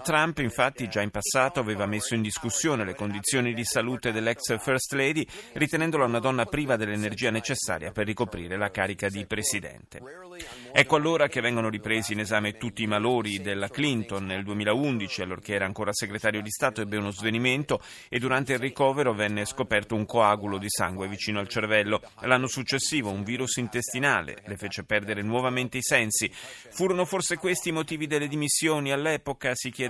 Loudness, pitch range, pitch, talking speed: -27 LUFS, 105-135 Hz, 115 Hz, 170 wpm